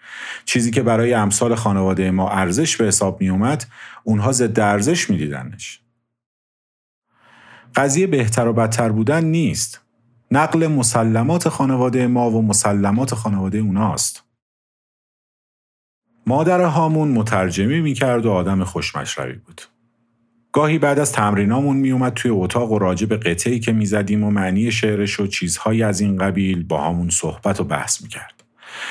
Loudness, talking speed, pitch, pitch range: -18 LUFS, 135 wpm, 115 Hz, 100-125 Hz